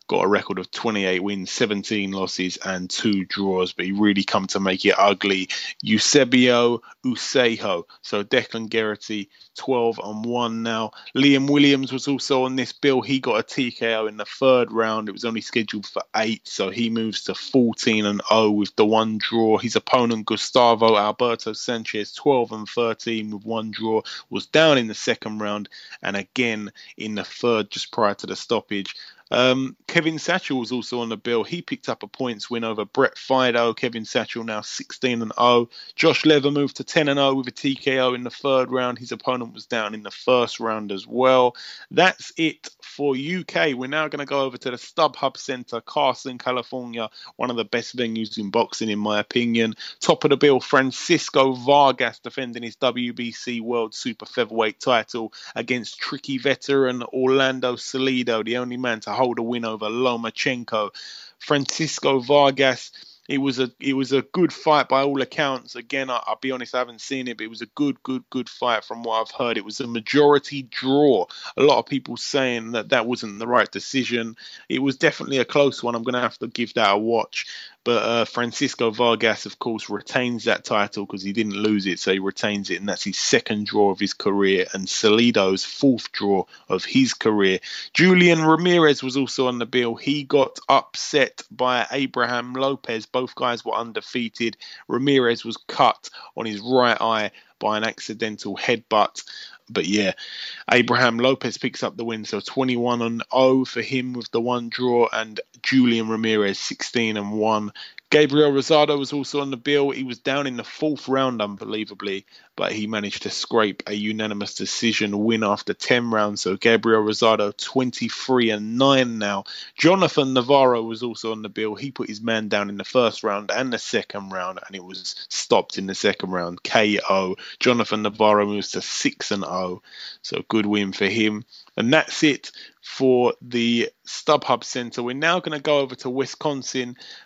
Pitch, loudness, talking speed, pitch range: 120 Hz, -22 LUFS, 185 wpm, 110-130 Hz